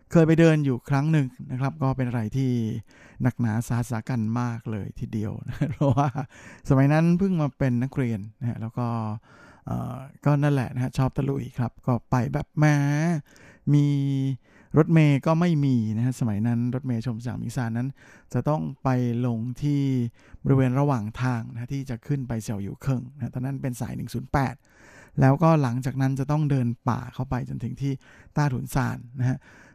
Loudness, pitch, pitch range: -25 LUFS, 130 Hz, 120-140 Hz